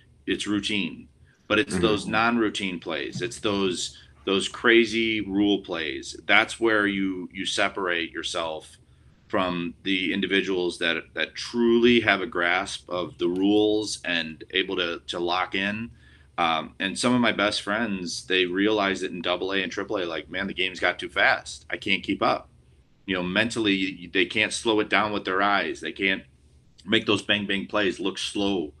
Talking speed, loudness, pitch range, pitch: 175 wpm, -25 LUFS, 90-105 Hz, 100 Hz